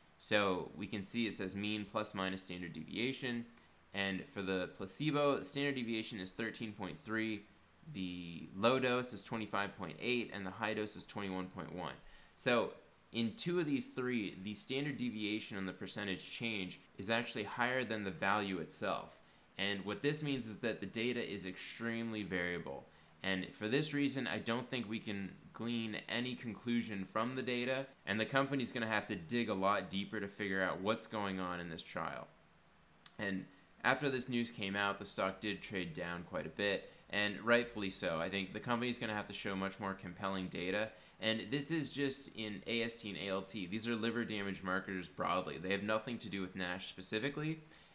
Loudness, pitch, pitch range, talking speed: -39 LUFS, 105 Hz, 95-120 Hz, 185 wpm